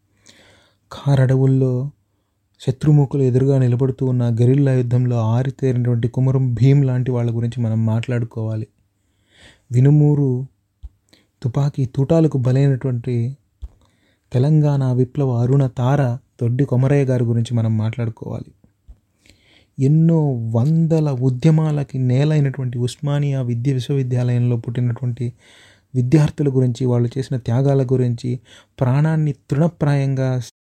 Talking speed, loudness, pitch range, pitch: 90 wpm, -18 LUFS, 115-135 Hz, 125 Hz